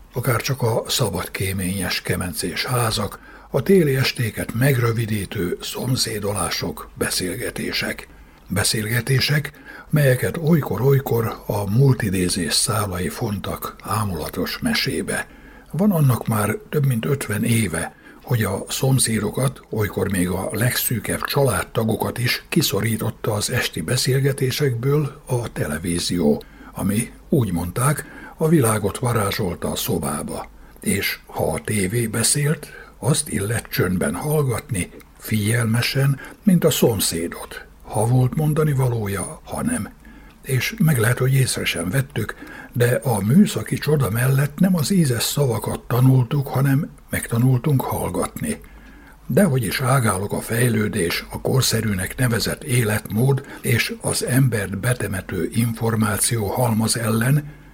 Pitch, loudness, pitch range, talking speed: 125 Hz, -21 LUFS, 110-140 Hz, 110 wpm